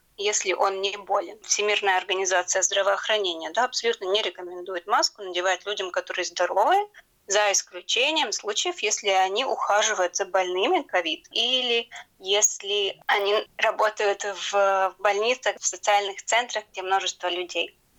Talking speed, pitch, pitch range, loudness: 125 wpm, 200 Hz, 190-225 Hz, -24 LUFS